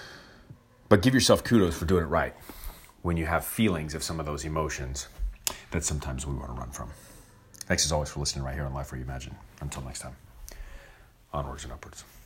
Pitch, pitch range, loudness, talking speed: 75 Hz, 65-90 Hz, -28 LUFS, 205 wpm